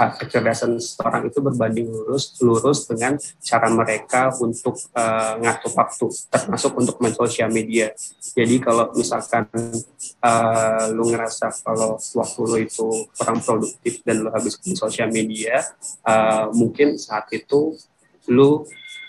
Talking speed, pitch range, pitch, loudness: 130 wpm, 110-125 Hz, 115 Hz, -20 LUFS